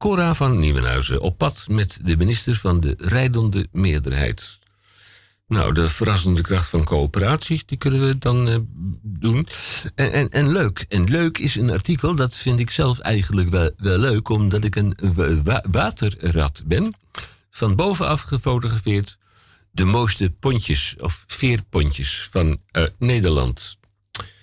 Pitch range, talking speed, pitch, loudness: 90-120 Hz, 145 wpm, 100 Hz, -20 LUFS